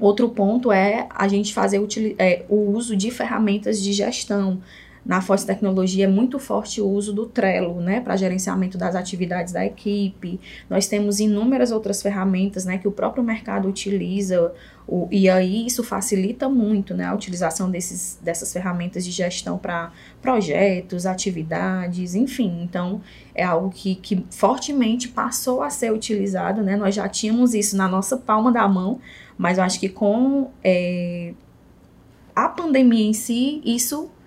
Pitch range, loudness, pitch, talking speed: 185-220 Hz, -21 LUFS, 200 Hz, 160 wpm